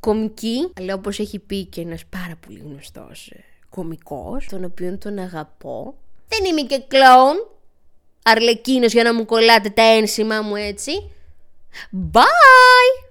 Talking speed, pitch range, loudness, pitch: 135 wpm, 180-245 Hz, -14 LUFS, 215 Hz